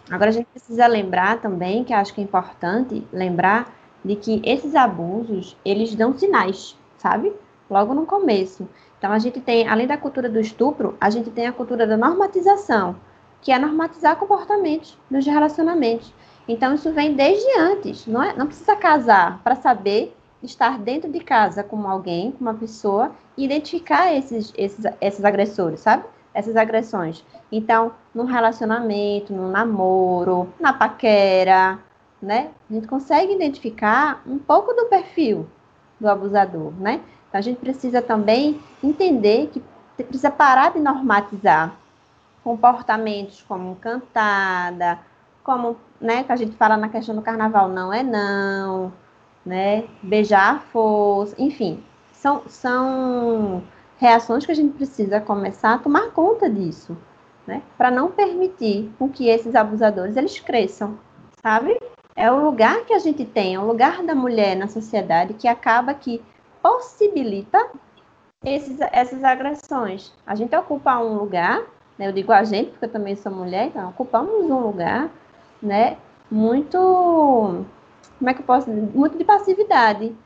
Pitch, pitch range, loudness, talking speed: 230 Hz, 205-280 Hz, -19 LUFS, 150 wpm